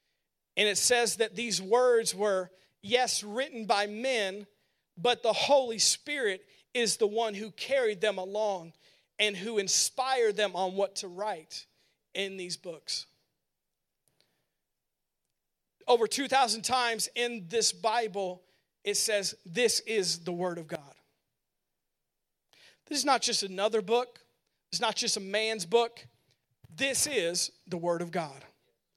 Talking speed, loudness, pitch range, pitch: 135 wpm, -29 LUFS, 185-235 Hz, 210 Hz